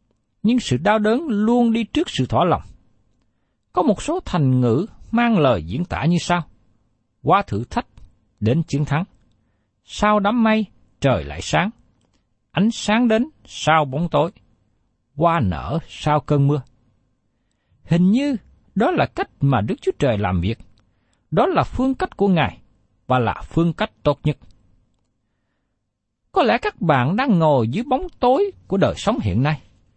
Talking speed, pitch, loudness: 160 wpm, 135 Hz, -20 LUFS